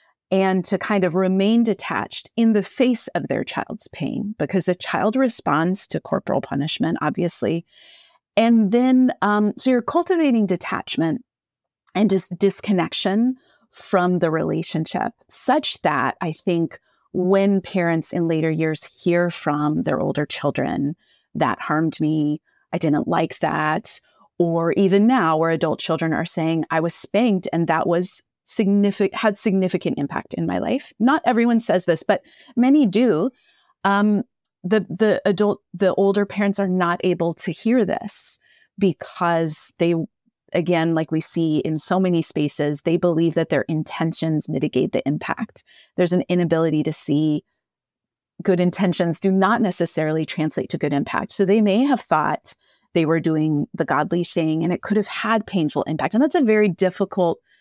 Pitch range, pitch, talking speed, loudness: 165-210 Hz, 185 Hz, 155 wpm, -21 LUFS